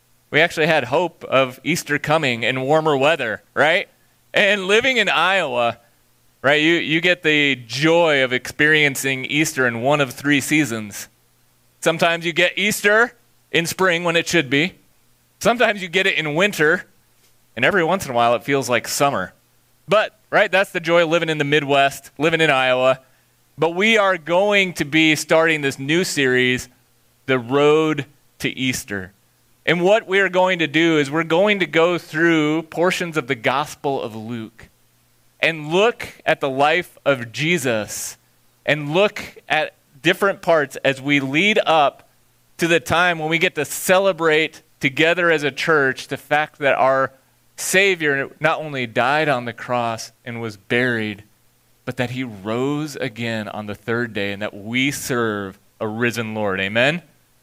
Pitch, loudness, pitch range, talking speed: 145 Hz, -18 LUFS, 120-165 Hz, 165 wpm